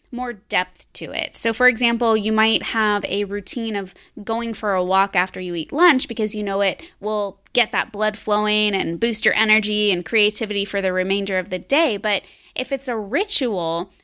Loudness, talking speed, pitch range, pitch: -20 LUFS, 200 wpm, 195-235 Hz, 210 Hz